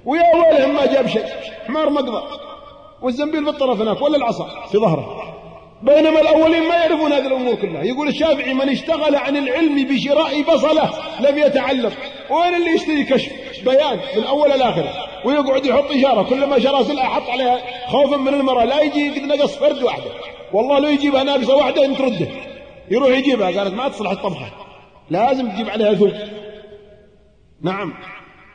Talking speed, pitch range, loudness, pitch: 160 wpm, 245-295 Hz, -17 LUFS, 275 Hz